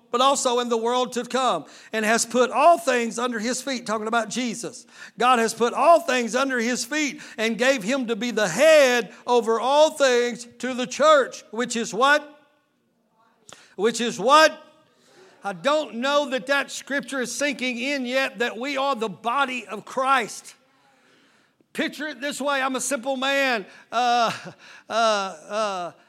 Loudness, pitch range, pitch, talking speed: -22 LUFS, 230-275 Hz, 250 Hz, 170 wpm